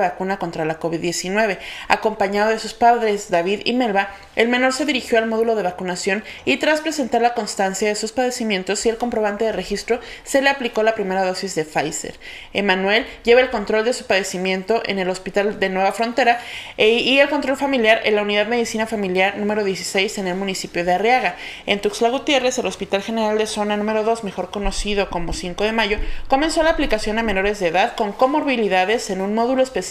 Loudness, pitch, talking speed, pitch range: -19 LUFS, 215 Hz, 200 wpm, 195-235 Hz